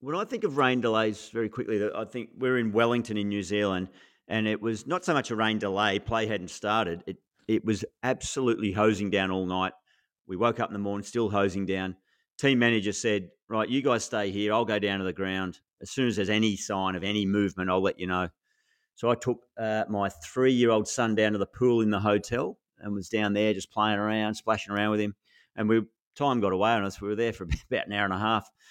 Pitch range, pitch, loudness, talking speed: 100-115 Hz, 105 Hz, -28 LUFS, 240 wpm